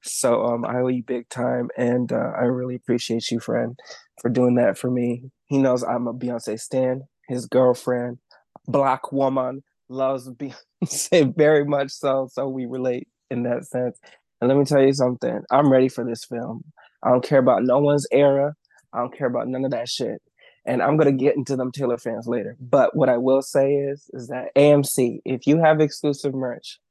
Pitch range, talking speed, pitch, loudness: 120-140 Hz, 200 wpm, 130 Hz, -22 LUFS